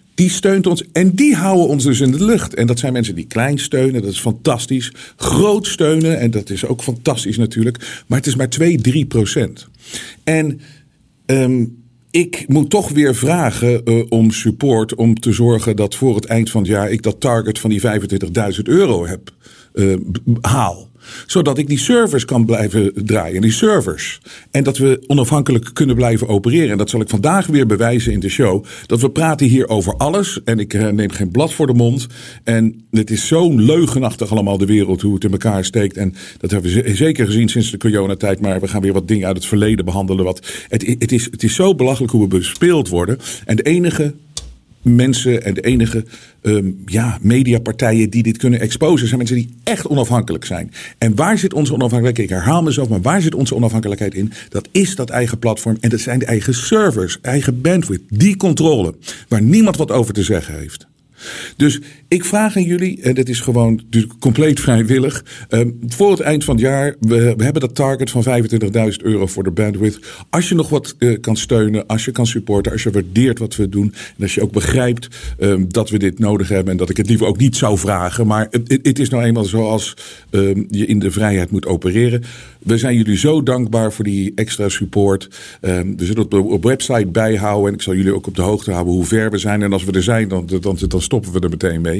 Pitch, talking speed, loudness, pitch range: 115 Hz, 205 wpm, -15 LUFS, 105-135 Hz